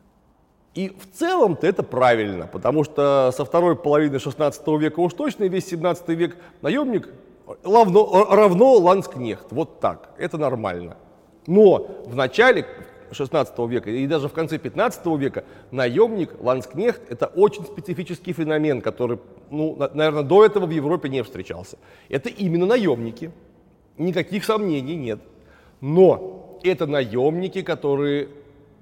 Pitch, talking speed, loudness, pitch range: 155 Hz, 125 wpm, -20 LUFS, 135-185 Hz